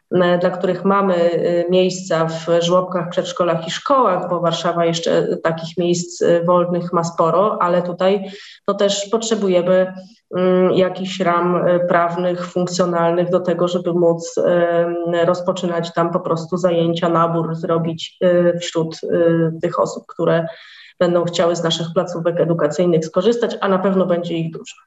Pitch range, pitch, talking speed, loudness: 170-185 Hz, 175 Hz, 130 wpm, -18 LUFS